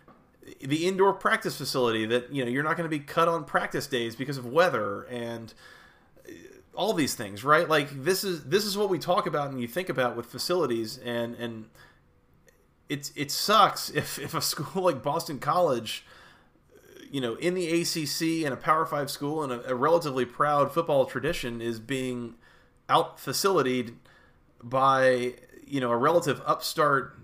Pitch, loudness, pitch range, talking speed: 140 Hz, -27 LUFS, 125-165 Hz, 170 wpm